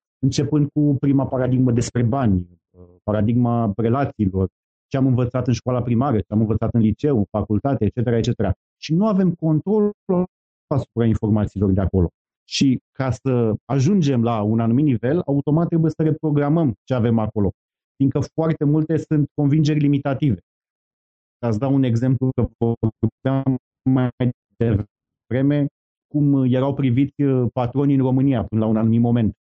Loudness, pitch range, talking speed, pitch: -20 LUFS, 110-140 Hz, 145 wpm, 125 Hz